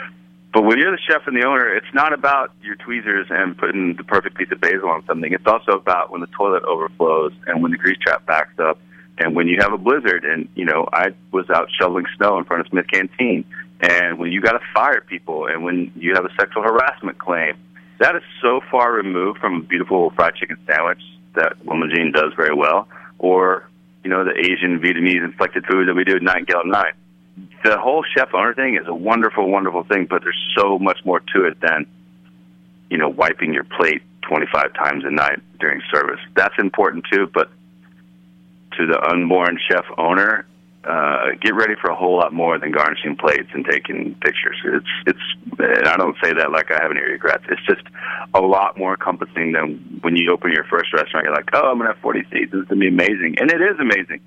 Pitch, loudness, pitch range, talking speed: 85 Hz, -17 LUFS, 60-90 Hz, 220 wpm